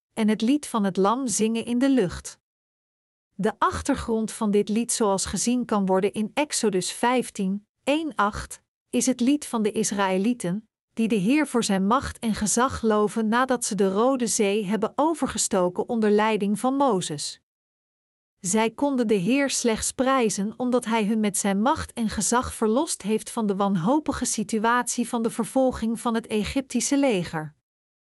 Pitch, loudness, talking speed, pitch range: 225 Hz, -24 LUFS, 160 wpm, 210-250 Hz